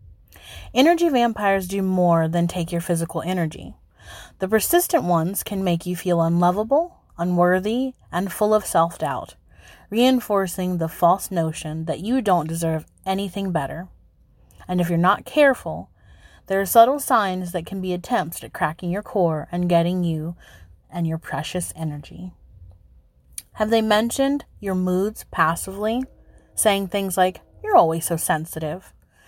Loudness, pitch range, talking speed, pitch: -22 LUFS, 160-205 Hz, 145 wpm, 180 Hz